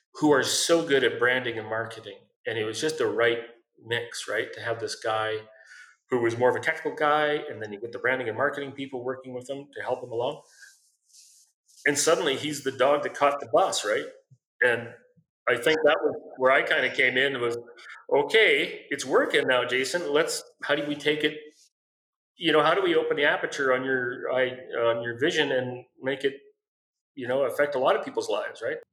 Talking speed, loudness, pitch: 210 wpm, -25 LUFS, 140 Hz